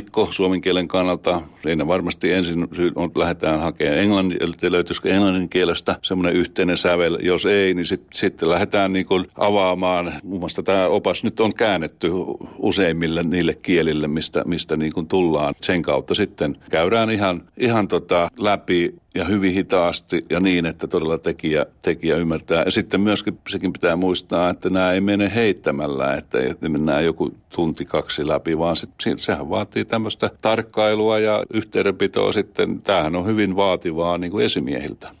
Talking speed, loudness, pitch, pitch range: 155 wpm, -20 LUFS, 90 Hz, 85-100 Hz